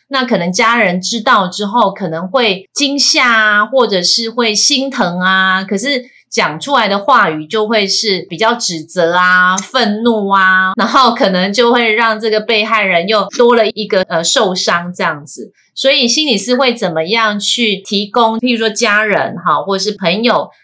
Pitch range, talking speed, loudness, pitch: 190-235 Hz, 255 characters per minute, -11 LUFS, 215 Hz